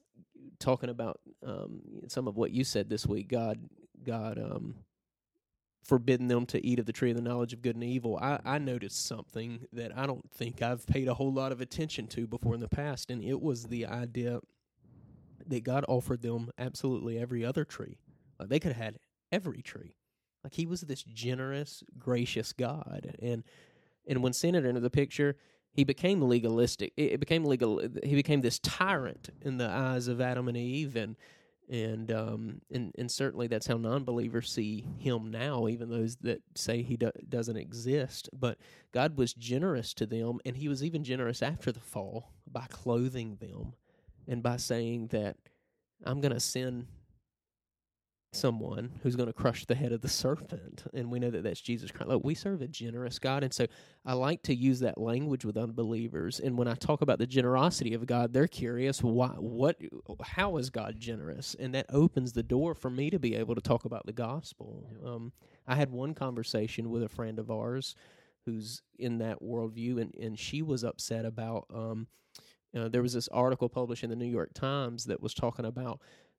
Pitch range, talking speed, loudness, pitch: 115-135 Hz, 195 wpm, -33 LUFS, 120 Hz